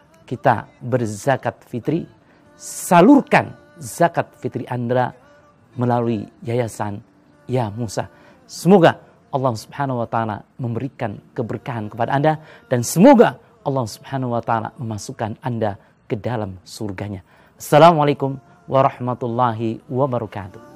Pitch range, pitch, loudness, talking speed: 115-140 Hz, 125 Hz, -19 LUFS, 100 wpm